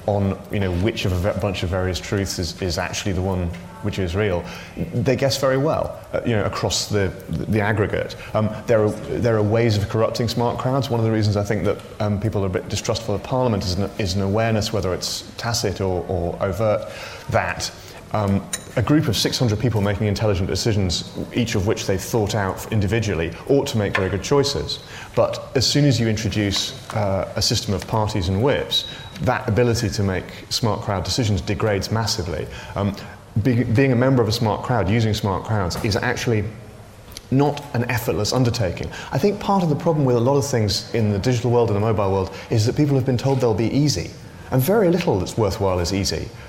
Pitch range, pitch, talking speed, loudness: 100-120 Hz, 105 Hz, 215 wpm, -21 LUFS